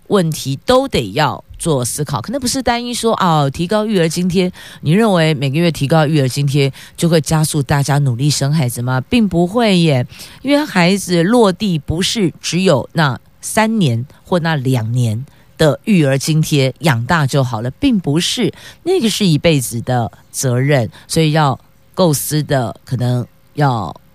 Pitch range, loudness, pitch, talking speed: 135-180 Hz, -15 LUFS, 155 Hz, 245 characters per minute